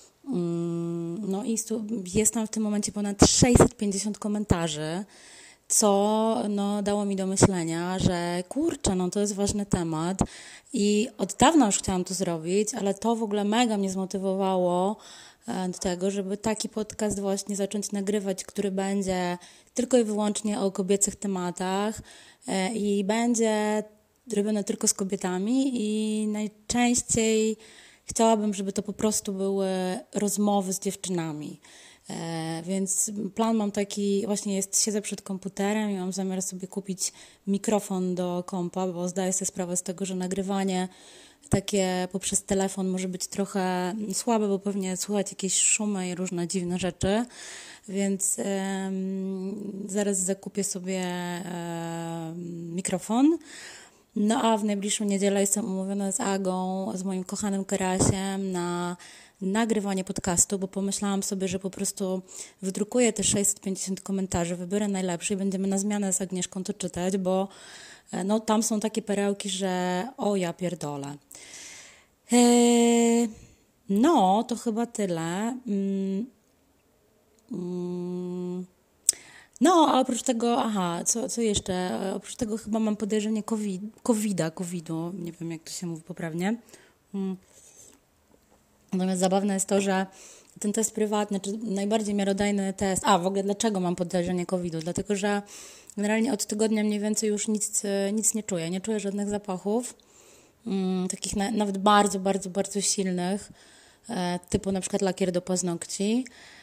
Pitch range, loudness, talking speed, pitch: 185-210 Hz, -27 LUFS, 140 wpm, 195 Hz